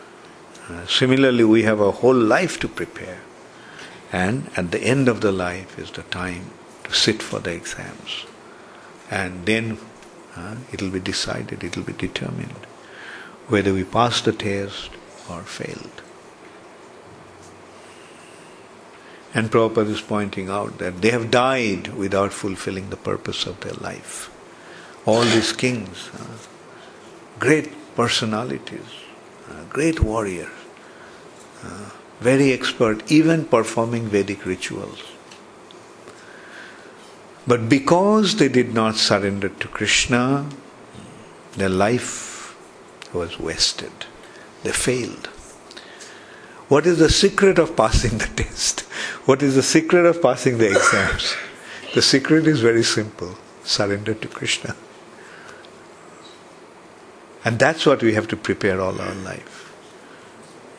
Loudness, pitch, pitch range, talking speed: -20 LUFS, 115 Hz, 100-130 Hz, 120 wpm